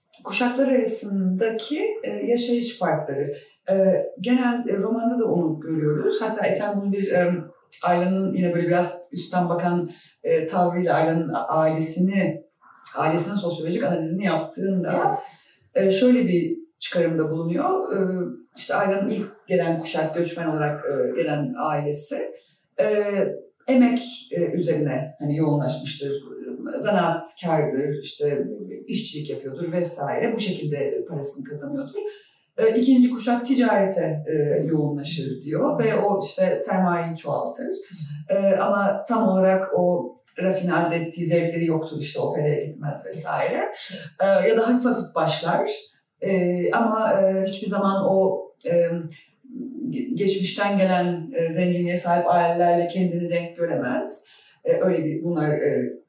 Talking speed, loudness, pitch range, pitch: 110 wpm, -23 LUFS, 165-210 Hz, 180 Hz